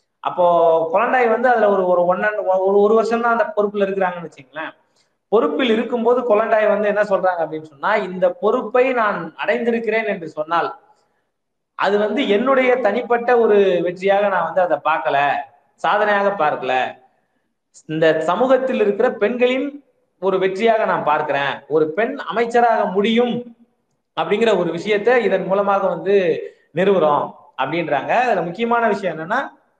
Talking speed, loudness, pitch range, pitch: 130 wpm, -18 LUFS, 180-235 Hz, 205 Hz